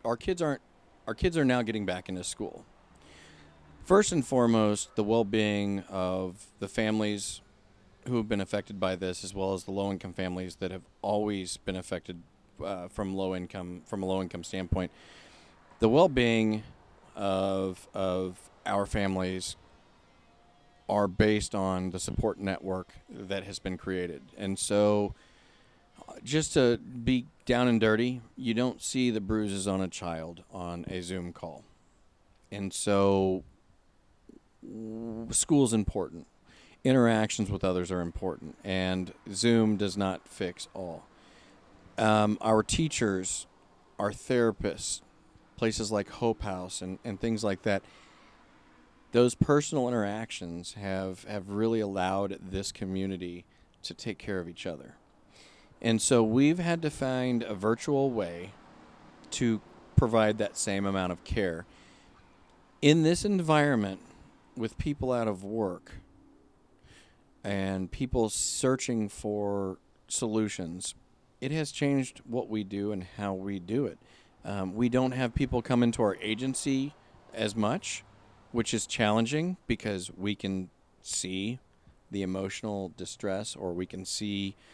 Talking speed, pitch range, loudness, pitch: 135 wpm, 95-115 Hz, -30 LUFS, 100 Hz